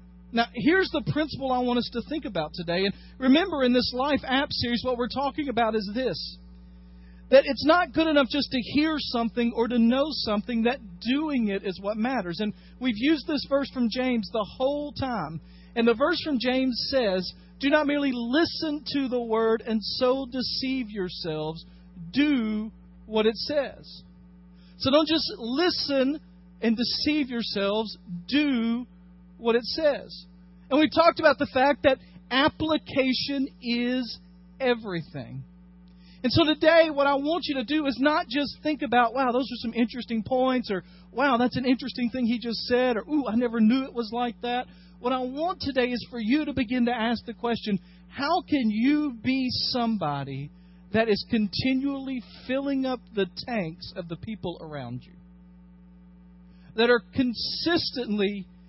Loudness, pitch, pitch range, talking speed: -26 LUFS, 240 Hz, 185-270 Hz, 170 wpm